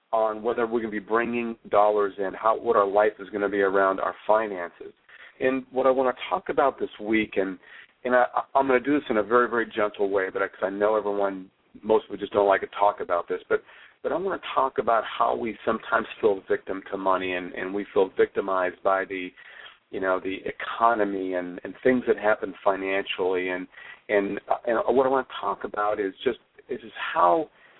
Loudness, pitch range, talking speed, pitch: -25 LUFS, 95-120 Hz, 225 wpm, 105 Hz